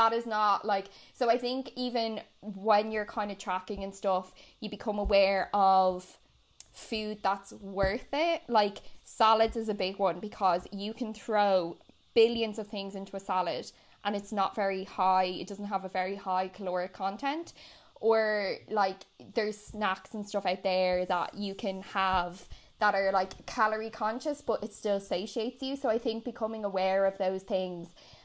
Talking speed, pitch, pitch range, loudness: 175 wpm, 205 Hz, 190-220 Hz, -31 LUFS